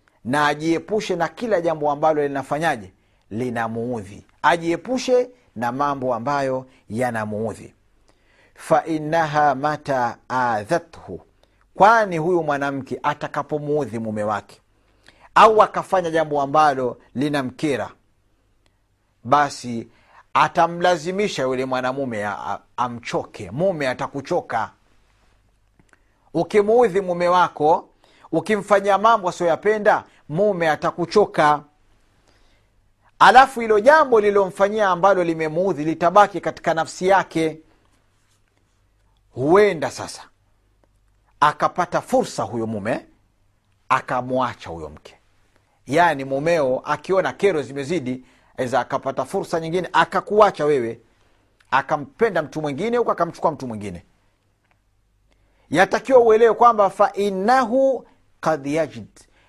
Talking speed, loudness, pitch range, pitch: 85 wpm, -20 LUFS, 110-180 Hz, 145 Hz